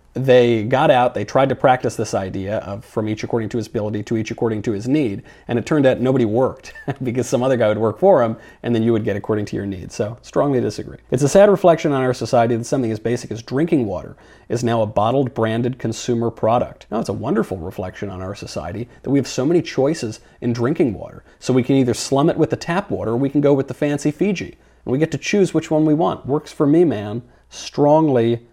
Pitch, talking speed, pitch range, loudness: 120 Hz, 250 wpm, 110-140 Hz, -19 LUFS